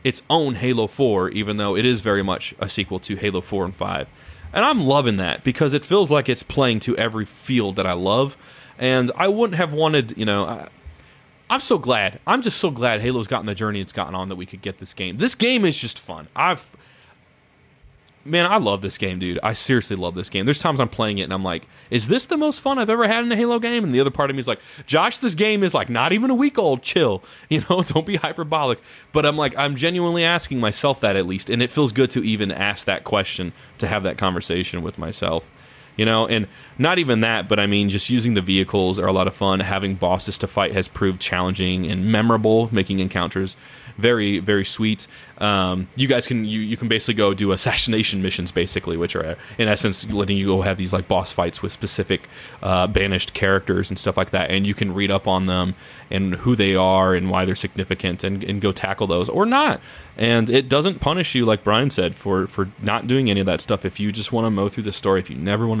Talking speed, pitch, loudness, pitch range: 240 wpm, 105 Hz, -20 LUFS, 95-135 Hz